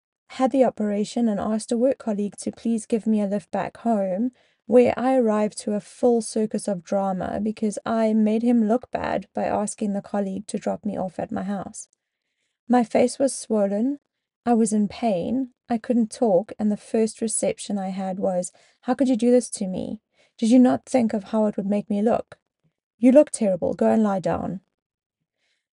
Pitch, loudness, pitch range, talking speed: 225 Hz, -23 LUFS, 205-245 Hz, 200 wpm